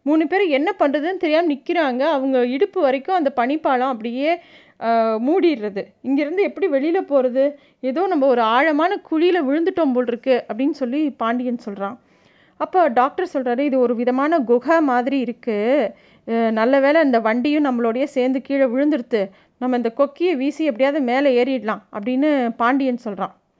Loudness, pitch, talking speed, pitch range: -19 LUFS, 275 Hz, 140 wpm, 245-310 Hz